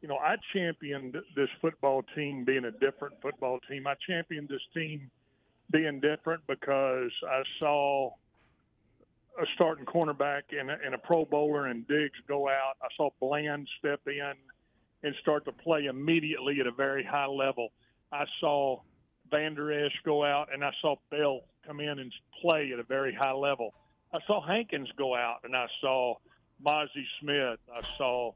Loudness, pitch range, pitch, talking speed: -31 LUFS, 135-150 Hz, 140 Hz, 165 wpm